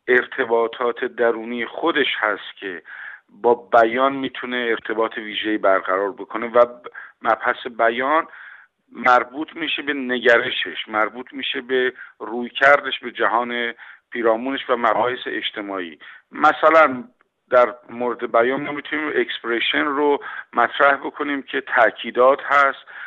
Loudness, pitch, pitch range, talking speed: -20 LUFS, 120 Hz, 115-135 Hz, 110 wpm